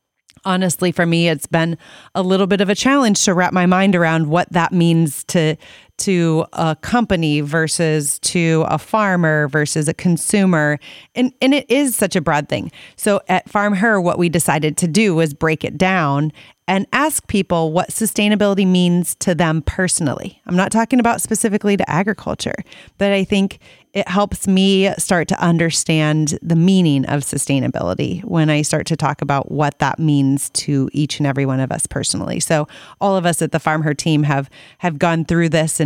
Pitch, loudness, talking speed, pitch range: 170 Hz, -17 LUFS, 185 wpm, 155-195 Hz